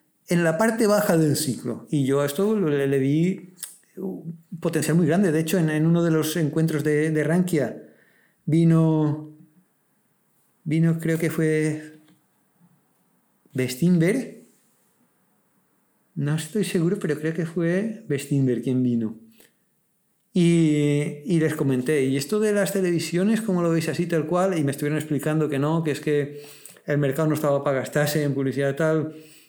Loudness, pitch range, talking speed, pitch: -23 LUFS, 145-175 Hz, 155 wpm, 155 Hz